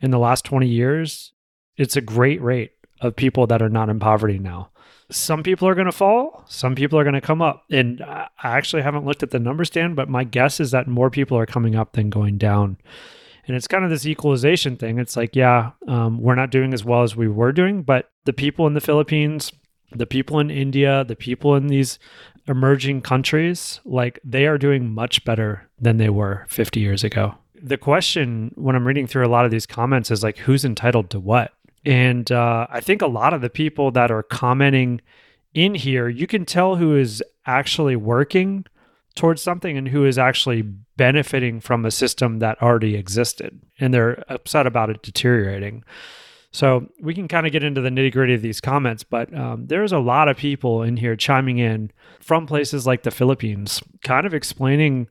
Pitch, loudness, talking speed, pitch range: 130 Hz, -19 LUFS, 205 wpm, 115-145 Hz